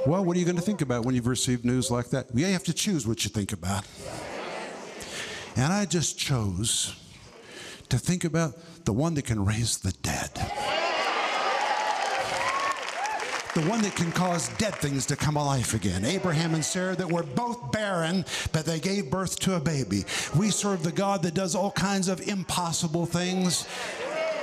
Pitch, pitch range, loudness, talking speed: 165 Hz, 125-185 Hz, -27 LUFS, 175 wpm